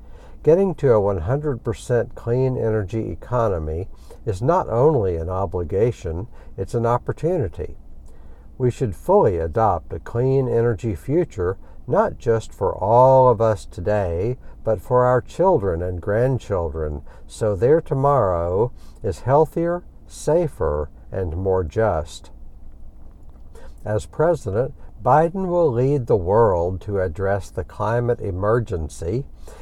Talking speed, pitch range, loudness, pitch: 115 wpm, 85-125 Hz, -21 LUFS, 105 Hz